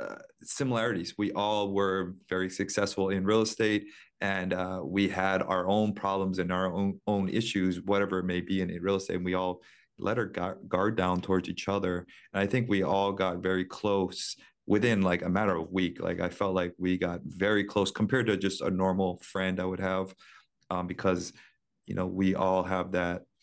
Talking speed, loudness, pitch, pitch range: 200 wpm, -30 LUFS, 95 Hz, 90-100 Hz